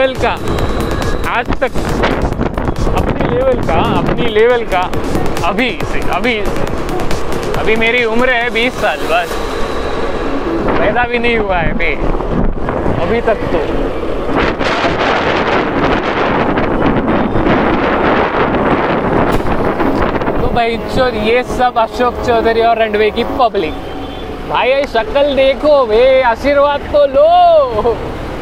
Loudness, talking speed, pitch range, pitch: -13 LUFS, 100 wpm, 230-285 Hz, 245 Hz